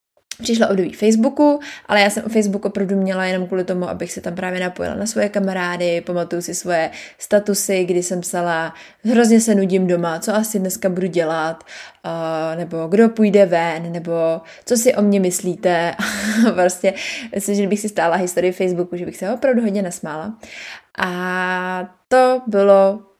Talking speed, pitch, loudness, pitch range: 170 wpm, 190 Hz, -18 LUFS, 175-210 Hz